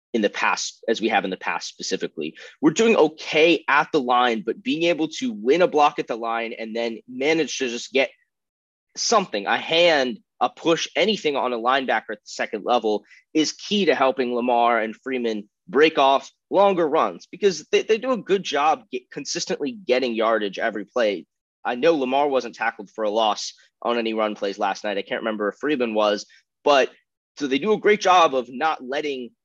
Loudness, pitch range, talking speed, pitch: -22 LUFS, 115-180 Hz, 200 wpm, 135 Hz